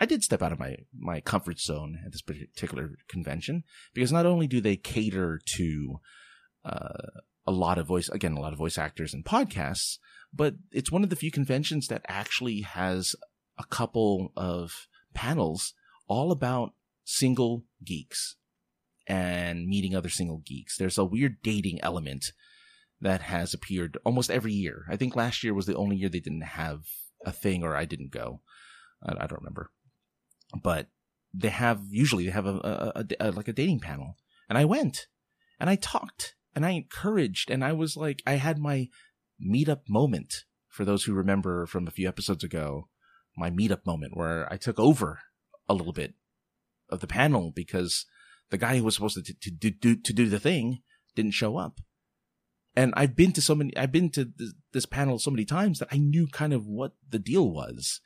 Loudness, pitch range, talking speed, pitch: -29 LUFS, 90-135 Hz, 190 wpm, 105 Hz